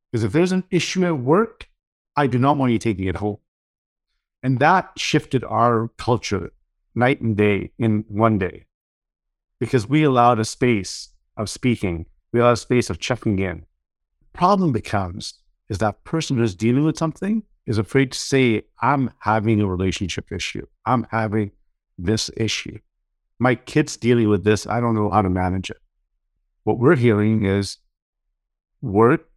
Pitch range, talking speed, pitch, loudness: 100-130 Hz, 160 wpm, 110 Hz, -20 LUFS